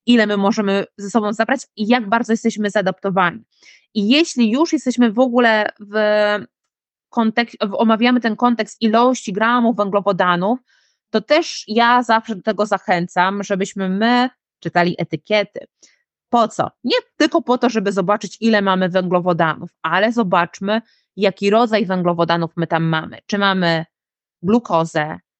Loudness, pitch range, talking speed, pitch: -17 LUFS, 190-235 Hz, 135 wpm, 215 Hz